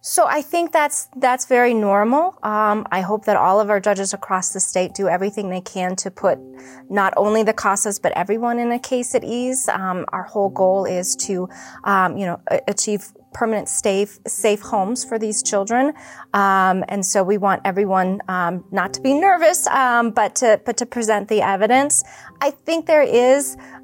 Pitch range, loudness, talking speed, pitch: 195-245 Hz, -19 LUFS, 190 wpm, 210 Hz